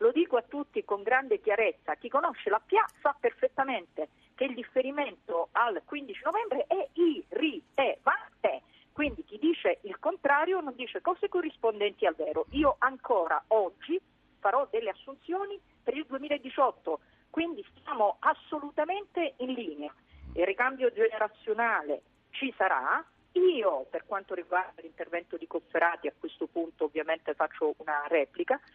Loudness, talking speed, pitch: -30 LUFS, 145 wpm, 260 Hz